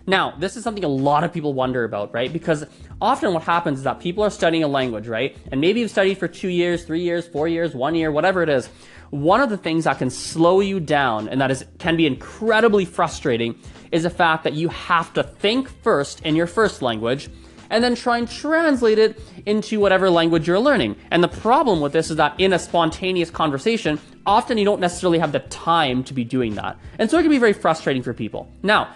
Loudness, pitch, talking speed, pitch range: -20 LUFS, 170 Hz, 230 wpm, 145-195 Hz